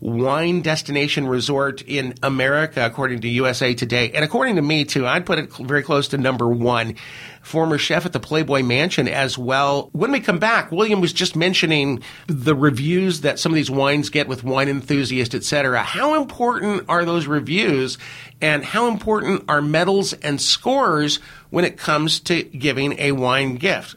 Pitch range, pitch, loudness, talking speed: 135-170 Hz, 145 Hz, -19 LUFS, 180 wpm